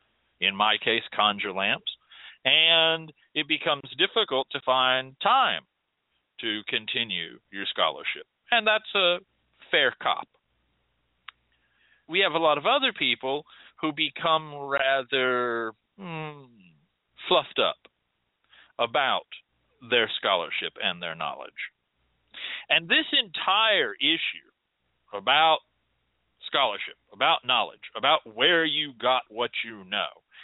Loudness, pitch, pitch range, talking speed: -24 LUFS, 150 Hz, 130-165 Hz, 110 wpm